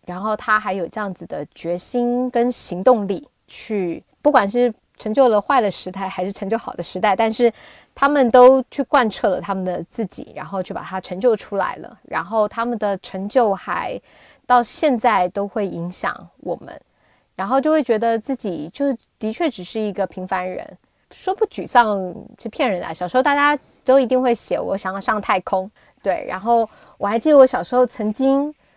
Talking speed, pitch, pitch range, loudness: 270 characters per minute, 220 Hz, 190-255 Hz, -19 LUFS